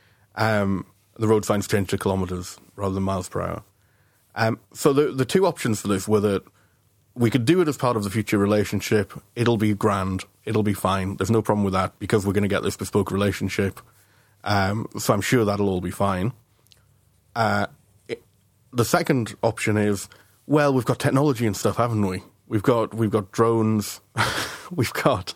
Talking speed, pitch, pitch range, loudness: 190 wpm, 105 Hz, 100-115 Hz, -23 LUFS